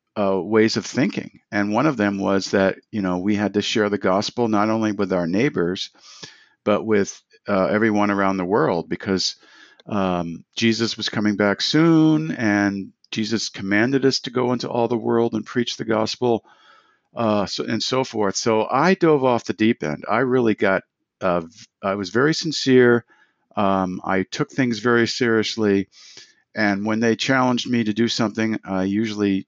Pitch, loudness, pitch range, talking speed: 110 Hz, -21 LUFS, 100-120 Hz, 180 wpm